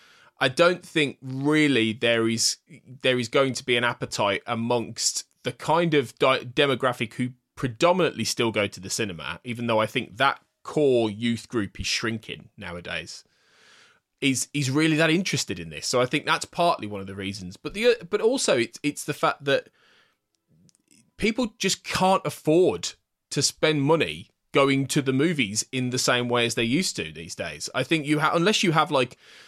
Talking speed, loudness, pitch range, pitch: 185 wpm, -24 LUFS, 120-155 Hz, 135 Hz